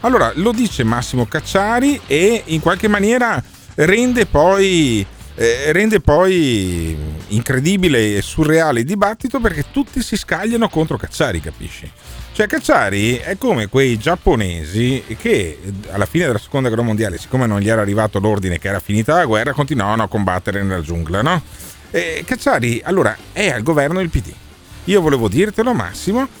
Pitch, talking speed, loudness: 130 Hz, 155 wpm, -16 LUFS